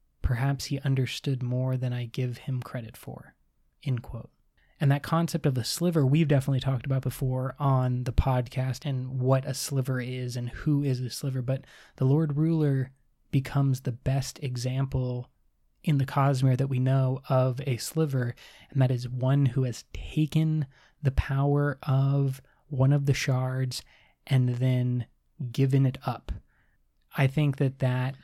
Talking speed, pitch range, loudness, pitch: 160 wpm, 125-140 Hz, -28 LUFS, 130 Hz